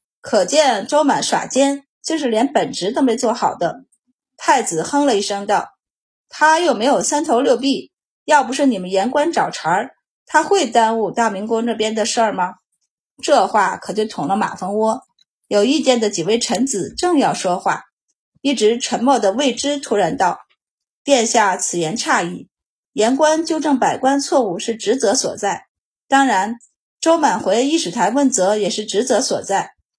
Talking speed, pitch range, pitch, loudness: 240 characters per minute, 215-285 Hz, 250 Hz, -17 LUFS